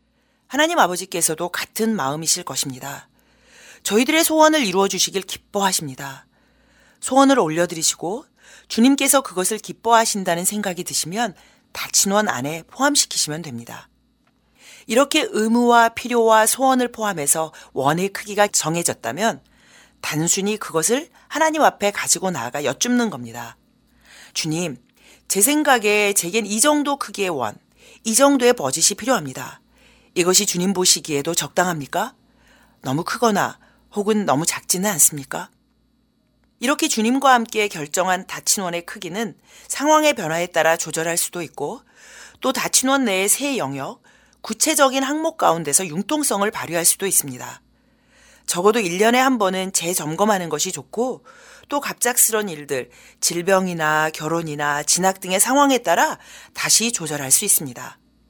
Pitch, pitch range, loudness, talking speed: 205 Hz, 170-250 Hz, -19 LUFS, 310 characters per minute